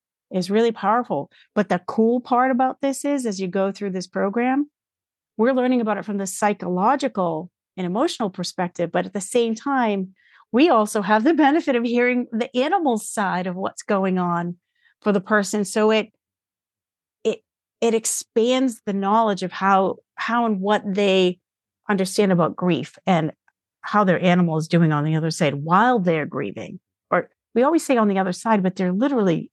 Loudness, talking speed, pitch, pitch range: -21 LUFS, 180 wpm, 210 Hz, 185-235 Hz